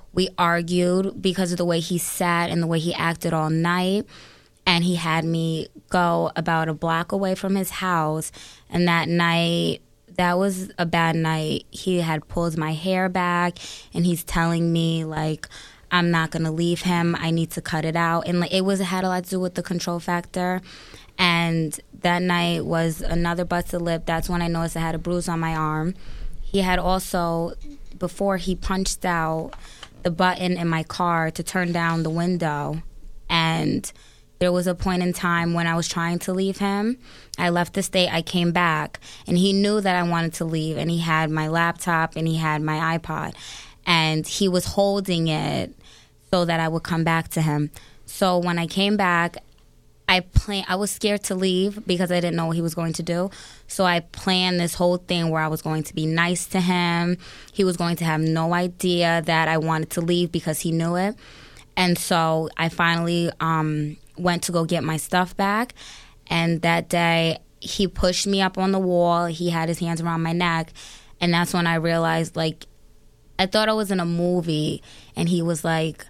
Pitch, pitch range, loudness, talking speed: 170 Hz, 165-180 Hz, -23 LUFS, 205 wpm